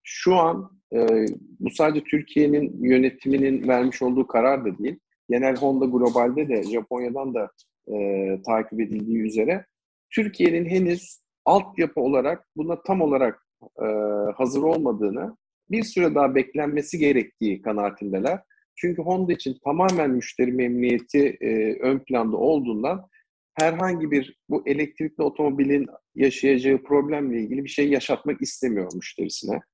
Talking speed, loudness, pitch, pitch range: 125 wpm, -23 LUFS, 140 Hz, 120-165 Hz